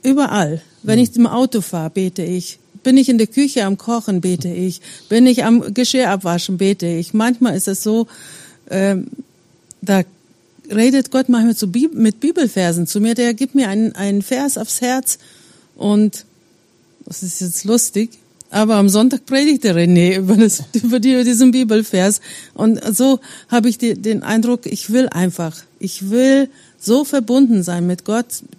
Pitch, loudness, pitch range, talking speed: 220 Hz, -15 LUFS, 190-250 Hz, 165 wpm